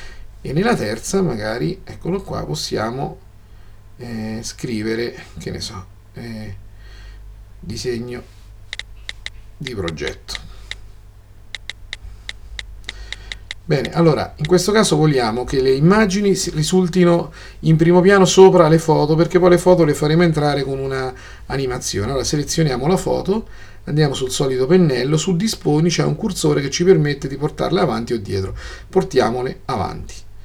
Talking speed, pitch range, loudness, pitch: 130 wpm, 100-165 Hz, -17 LUFS, 125 Hz